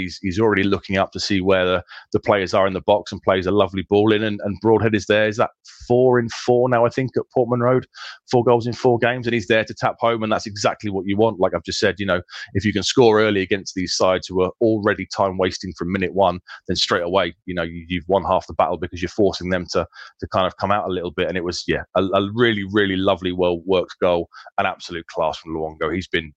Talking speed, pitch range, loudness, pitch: 270 wpm, 90-110 Hz, -20 LUFS, 100 Hz